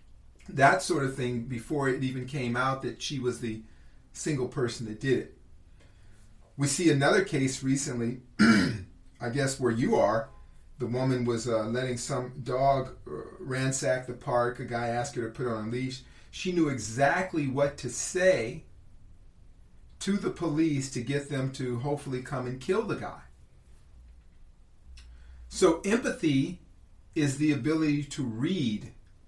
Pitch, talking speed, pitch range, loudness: 125 Hz, 150 wpm, 115-140 Hz, -29 LUFS